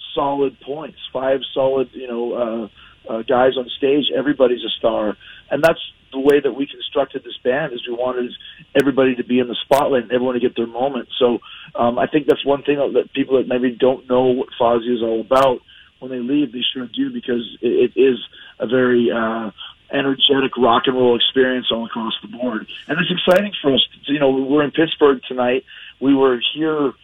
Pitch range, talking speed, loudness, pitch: 125-140 Hz, 205 wpm, -18 LUFS, 130 Hz